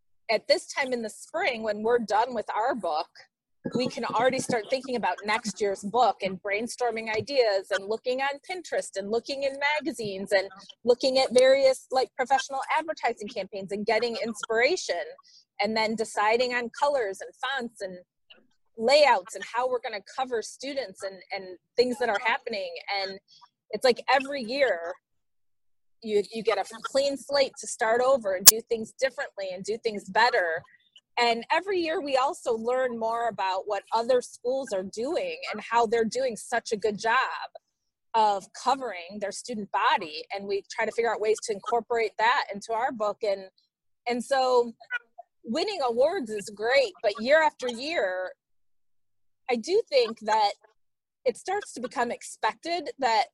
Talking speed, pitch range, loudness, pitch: 165 wpm, 205-265 Hz, -27 LUFS, 230 Hz